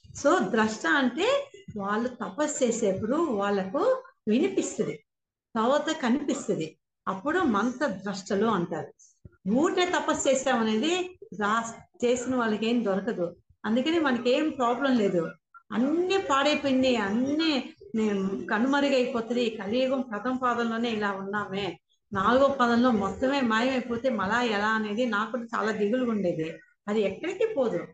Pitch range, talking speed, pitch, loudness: 205-275 Hz, 110 wpm, 240 Hz, -27 LUFS